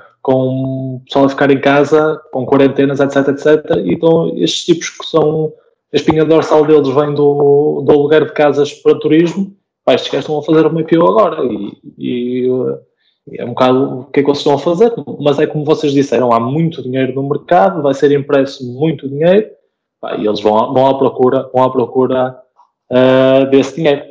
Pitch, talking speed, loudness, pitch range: 145 Hz, 200 wpm, -12 LUFS, 130-155 Hz